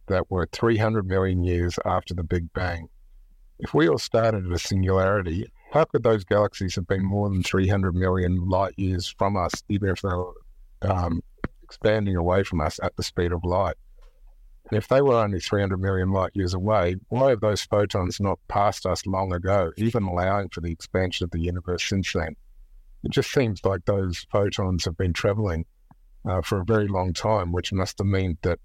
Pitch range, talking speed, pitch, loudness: 90-100 Hz, 195 wpm, 95 Hz, -25 LUFS